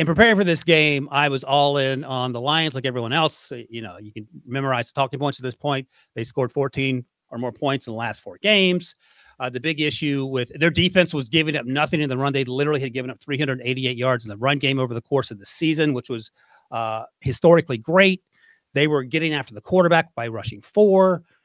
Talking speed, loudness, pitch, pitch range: 230 wpm, -21 LUFS, 140 Hz, 125-160 Hz